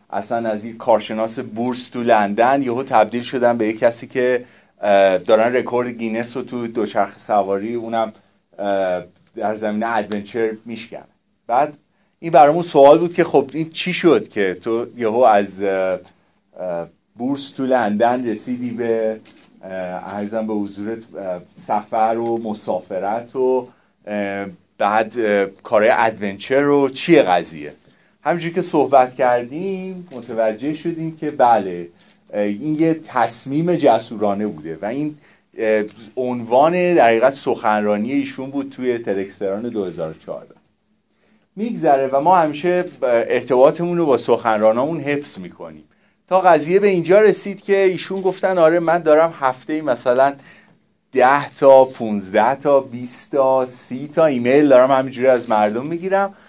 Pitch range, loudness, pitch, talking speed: 110-150 Hz, -18 LUFS, 125 Hz, 125 wpm